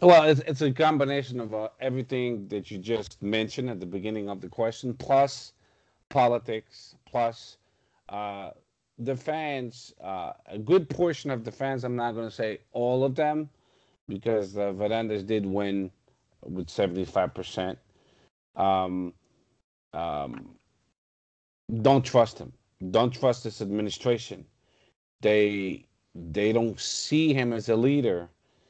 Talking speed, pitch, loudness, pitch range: 135 wpm, 115 Hz, -27 LUFS, 100-130 Hz